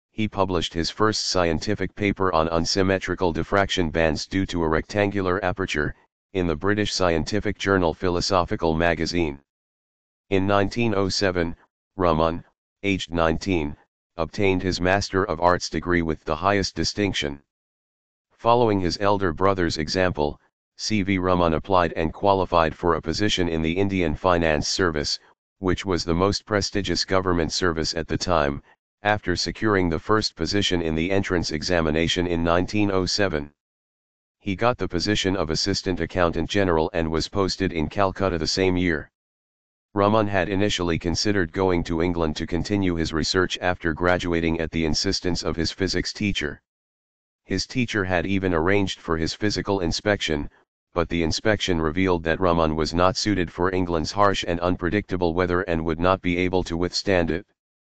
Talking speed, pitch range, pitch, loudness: 150 wpm, 80-95 Hz, 90 Hz, -23 LUFS